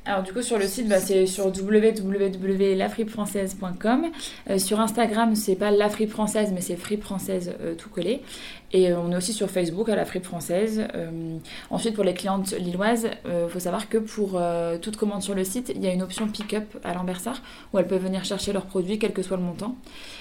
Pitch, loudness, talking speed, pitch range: 200 Hz, -25 LUFS, 215 wpm, 185-220 Hz